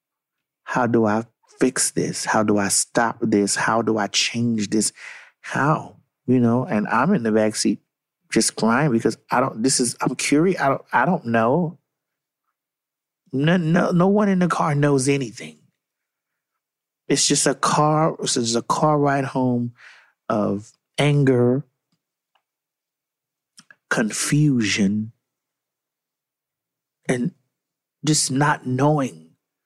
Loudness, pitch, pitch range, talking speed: -20 LUFS, 130 Hz, 115-150 Hz, 130 wpm